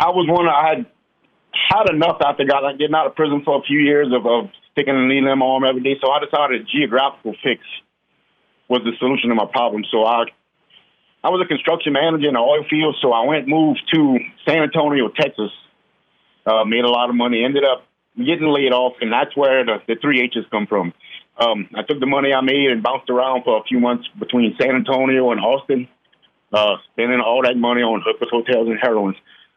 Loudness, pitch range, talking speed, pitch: -17 LUFS, 120-150 Hz, 220 wpm, 130 Hz